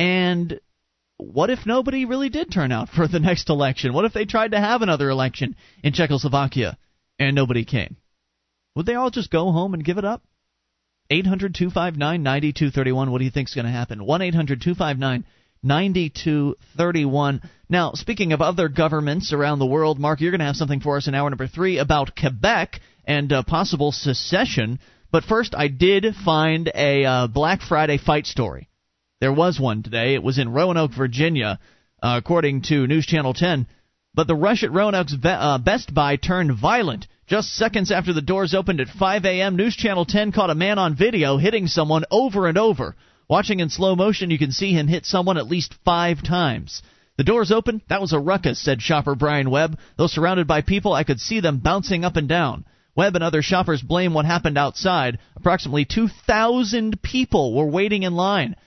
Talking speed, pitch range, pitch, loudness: 190 wpm, 140-190 Hz, 160 Hz, -20 LUFS